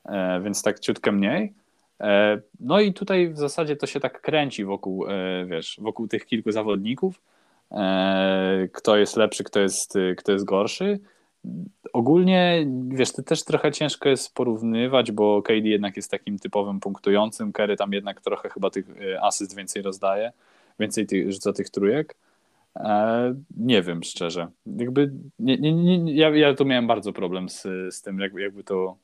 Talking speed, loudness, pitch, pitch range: 155 wpm, -23 LUFS, 105 Hz, 100-145 Hz